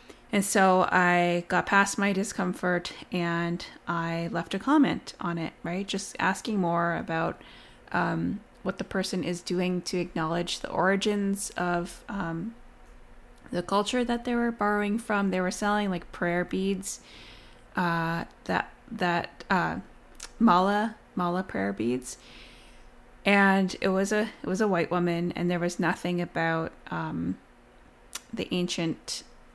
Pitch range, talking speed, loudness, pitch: 175-200 Hz, 140 wpm, -28 LUFS, 180 Hz